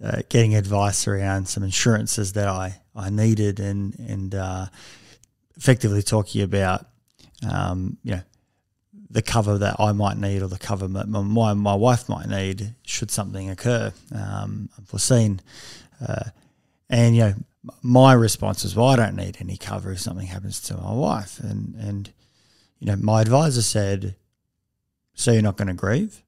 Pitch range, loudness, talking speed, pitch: 100-115 Hz, -22 LUFS, 160 wpm, 105 Hz